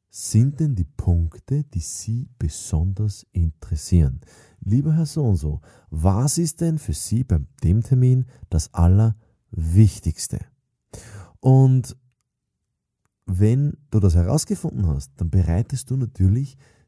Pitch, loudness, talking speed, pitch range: 105 Hz, -21 LUFS, 115 wpm, 90-130 Hz